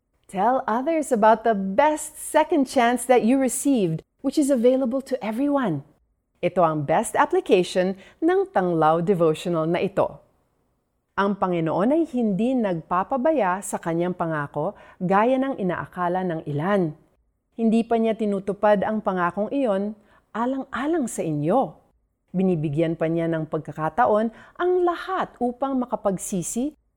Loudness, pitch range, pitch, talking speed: -23 LUFS, 175-260 Hz, 205 Hz, 125 wpm